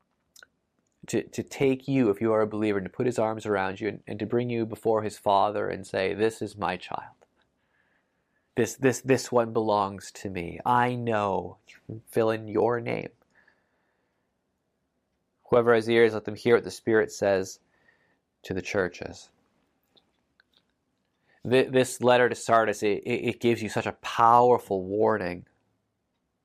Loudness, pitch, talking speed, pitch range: -26 LUFS, 110 Hz, 155 wpm, 105-120 Hz